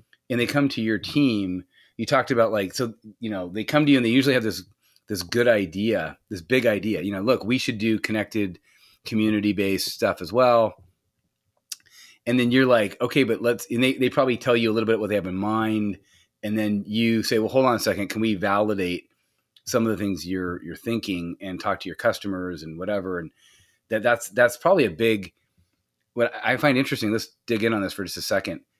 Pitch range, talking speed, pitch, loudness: 95-120 Hz, 225 wpm, 110 Hz, -23 LUFS